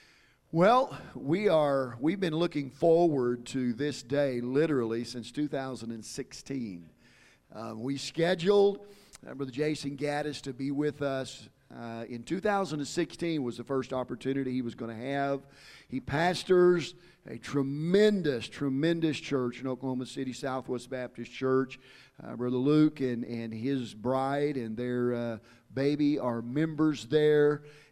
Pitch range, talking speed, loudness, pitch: 125-150 Hz, 135 wpm, -30 LUFS, 135 Hz